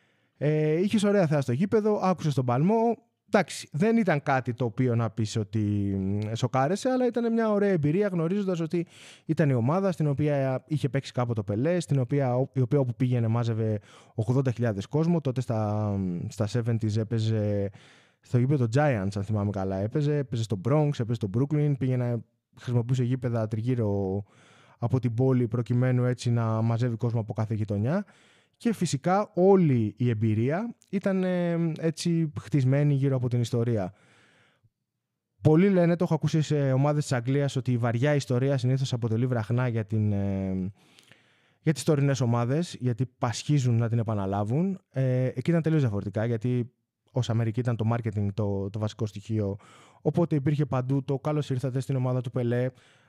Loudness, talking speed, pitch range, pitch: -27 LUFS, 165 wpm, 115-150 Hz, 125 Hz